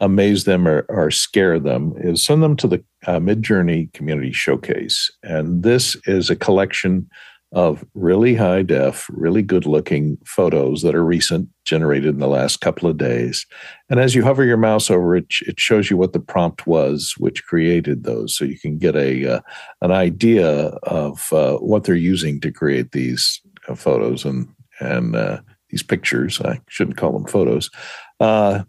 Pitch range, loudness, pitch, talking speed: 75-105 Hz, -18 LUFS, 90 Hz, 180 wpm